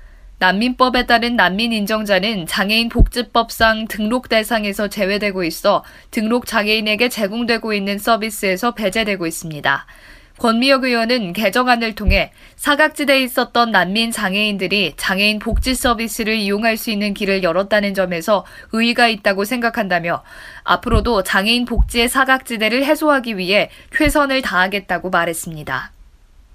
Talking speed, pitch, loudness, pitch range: 345 characters per minute, 220 Hz, -17 LUFS, 195-235 Hz